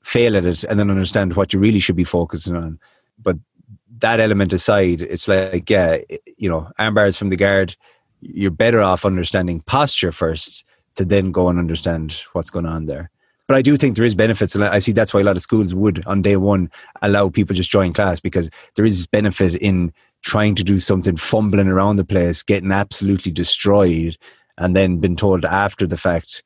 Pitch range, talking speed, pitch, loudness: 90-105 Hz, 205 wpm, 95 Hz, -17 LUFS